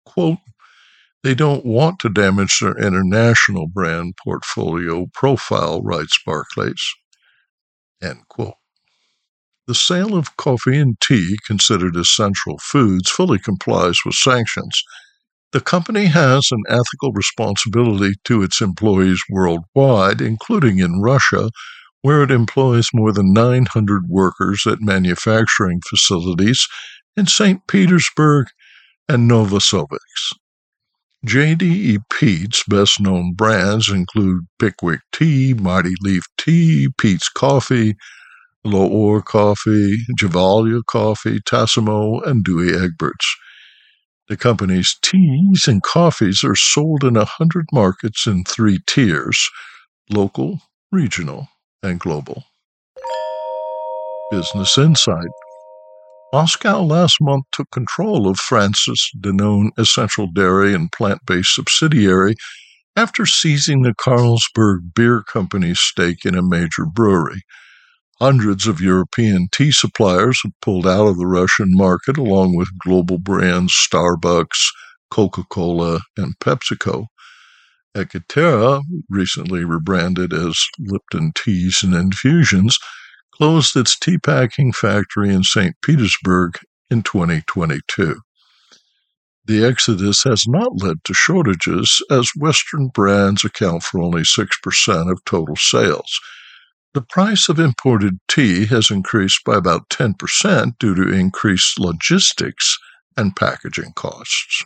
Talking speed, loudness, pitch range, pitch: 110 wpm, -15 LUFS, 95-135 Hz, 110 Hz